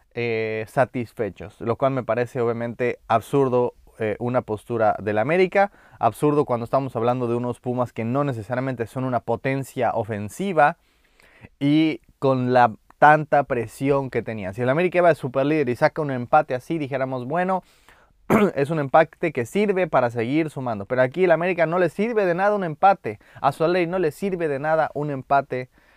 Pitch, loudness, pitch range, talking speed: 135 Hz, -22 LUFS, 120-160 Hz, 175 wpm